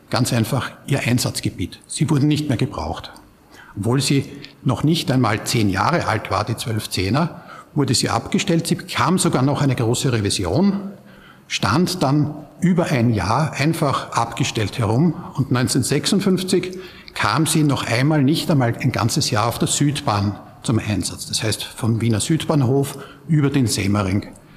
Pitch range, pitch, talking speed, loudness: 115-155 Hz, 135 Hz, 155 wpm, -20 LUFS